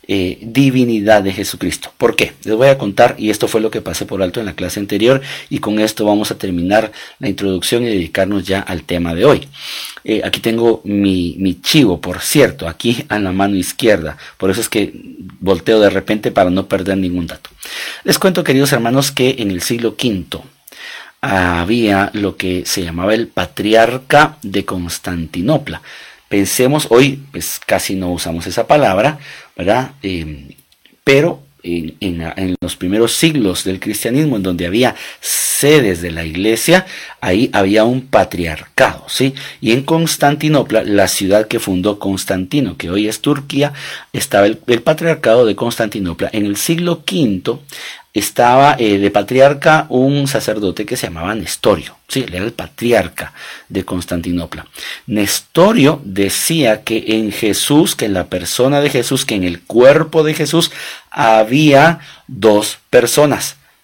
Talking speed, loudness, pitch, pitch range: 160 wpm, -14 LUFS, 105 Hz, 95-125 Hz